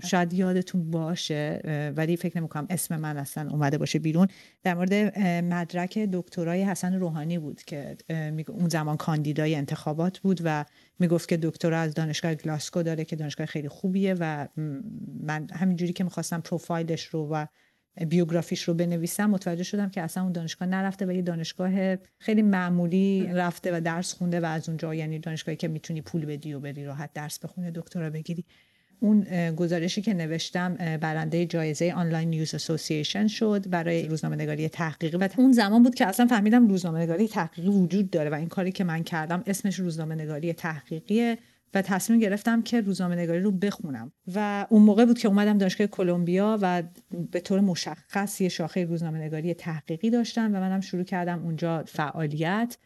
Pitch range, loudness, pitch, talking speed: 160-190 Hz, -27 LUFS, 175 Hz, 170 wpm